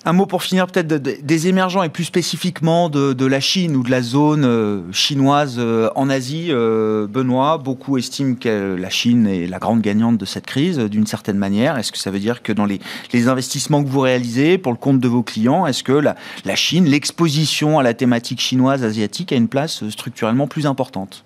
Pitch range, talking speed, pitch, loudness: 110-150 Hz, 205 wpm, 130 Hz, -17 LUFS